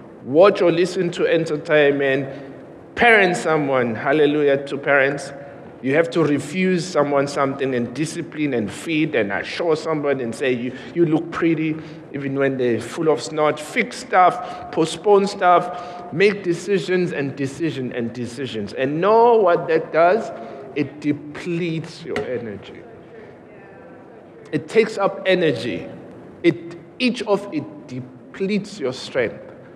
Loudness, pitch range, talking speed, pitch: -20 LUFS, 140-180 Hz, 130 wpm, 160 Hz